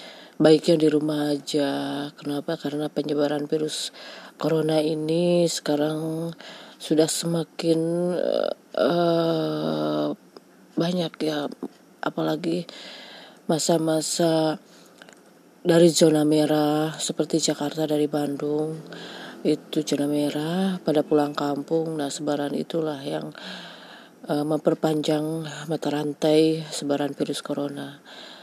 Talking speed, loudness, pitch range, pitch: 90 wpm, -24 LUFS, 145-160 Hz, 155 Hz